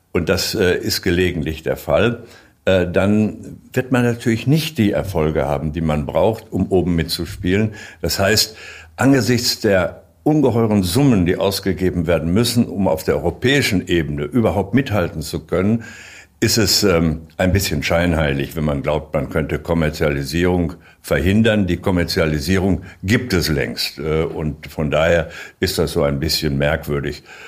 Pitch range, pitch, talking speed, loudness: 80-110 Hz, 90 Hz, 140 wpm, -18 LUFS